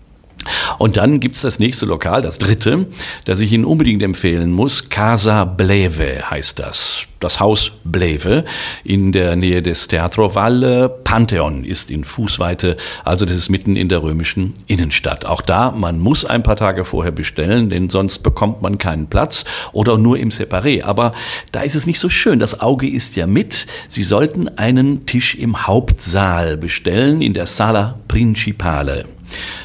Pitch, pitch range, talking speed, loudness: 100 Hz, 90-115 Hz, 165 wpm, -15 LUFS